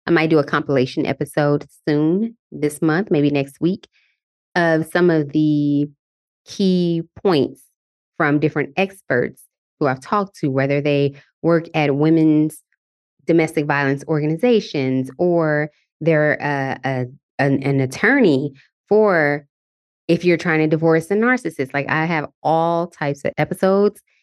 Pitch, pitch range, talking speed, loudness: 155 Hz, 140-170 Hz, 135 wpm, -19 LUFS